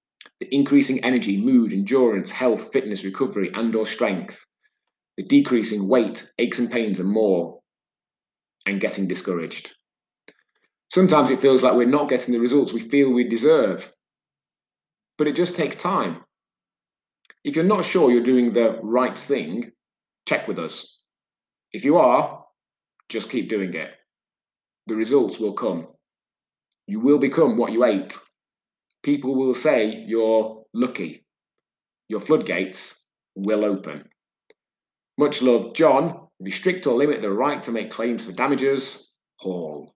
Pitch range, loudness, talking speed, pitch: 115-140 Hz, -21 LUFS, 140 wpm, 125 Hz